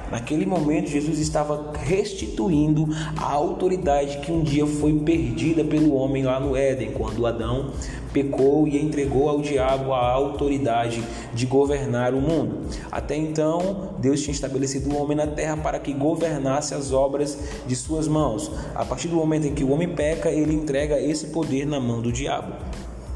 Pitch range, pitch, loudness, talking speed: 135-155 Hz, 145 Hz, -23 LUFS, 170 wpm